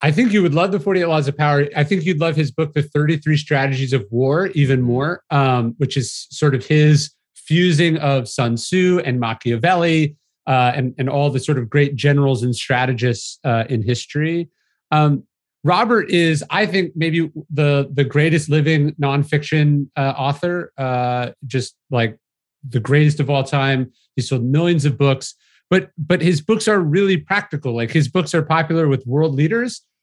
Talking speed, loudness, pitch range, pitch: 180 wpm, -18 LUFS, 135-165 Hz, 145 Hz